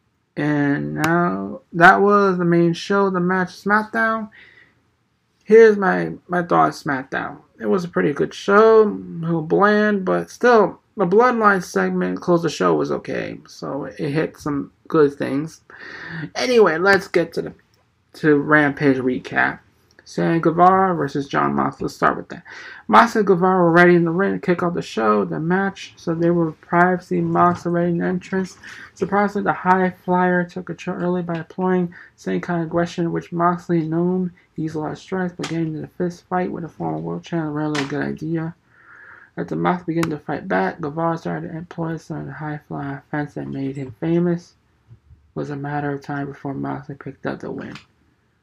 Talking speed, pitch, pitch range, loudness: 190 wpm, 170 Hz, 150-185 Hz, -19 LUFS